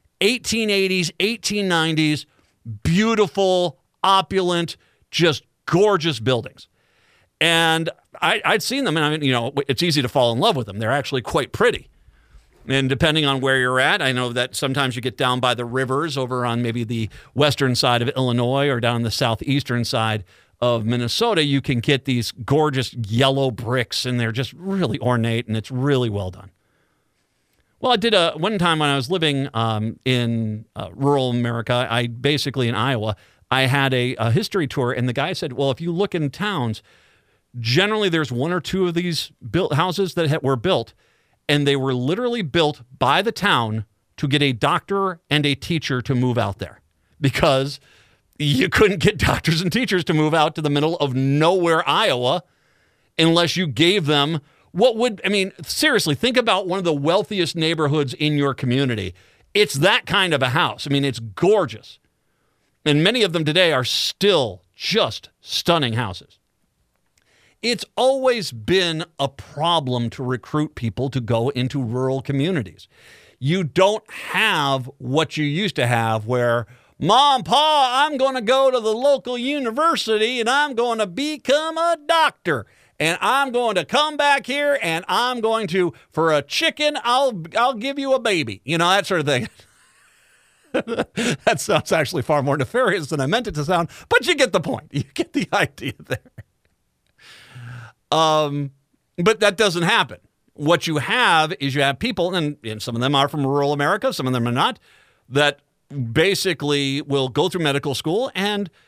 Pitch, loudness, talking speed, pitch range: 145 Hz, -20 LUFS, 175 wpm, 125-190 Hz